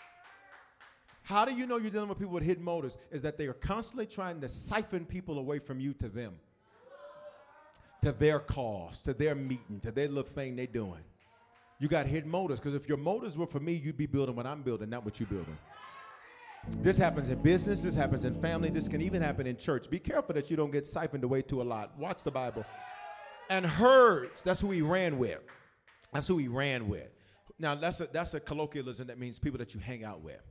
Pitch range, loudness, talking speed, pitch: 125-170 Hz, -33 LUFS, 220 wpm, 145 Hz